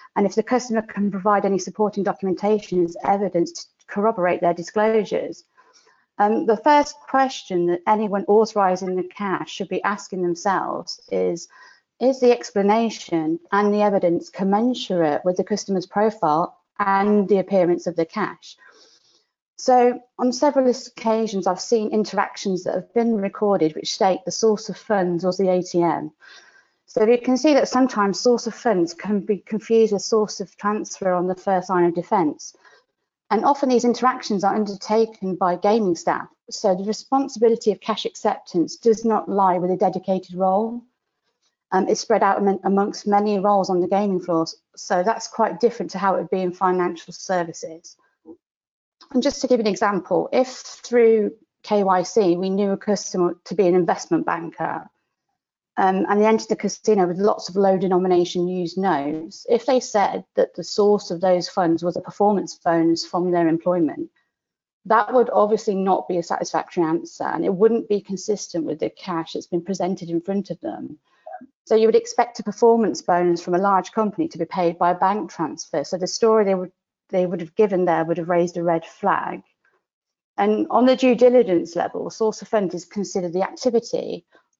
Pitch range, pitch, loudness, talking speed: 180-225 Hz, 200 Hz, -21 LUFS, 180 wpm